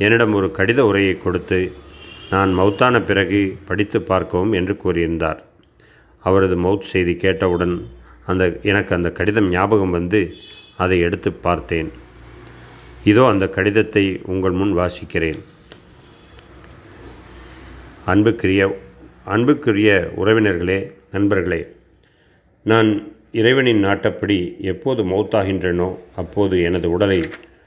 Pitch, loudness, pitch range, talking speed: 95 Hz, -18 LUFS, 90-100 Hz, 95 wpm